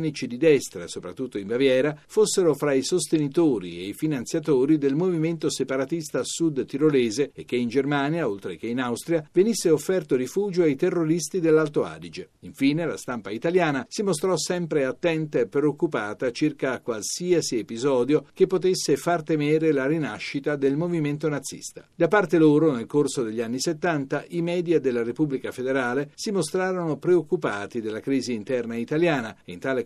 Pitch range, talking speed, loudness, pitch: 135-170 Hz, 155 wpm, -24 LUFS, 155 Hz